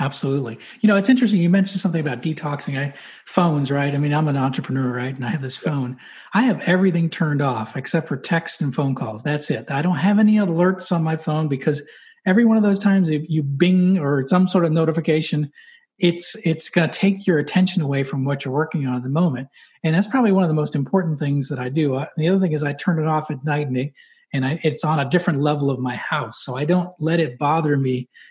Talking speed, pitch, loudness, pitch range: 245 wpm, 155 Hz, -20 LUFS, 140-180 Hz